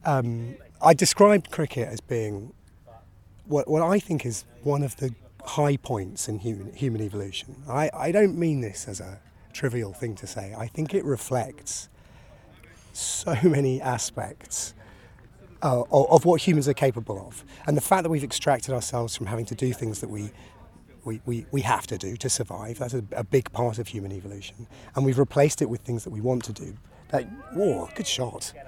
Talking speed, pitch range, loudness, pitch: 190 wpm, 110-140 Hz, -26 LUFS, 120 Hz